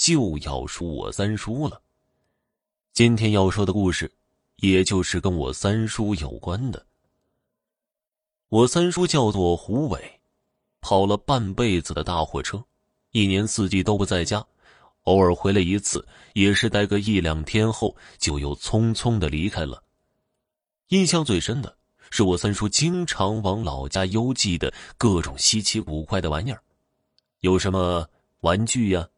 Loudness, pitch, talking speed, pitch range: -23 LUFS, 100 Hz, 215 characters per minute, 90-115 Hz